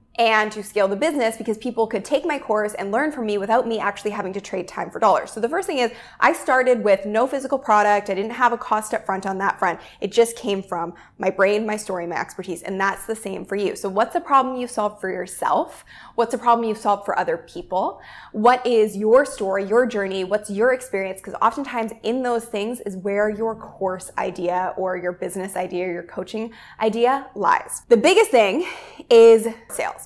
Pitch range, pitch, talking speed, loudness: 195-235 Hz, 215 Hz, 220 wpm, -21 LUFS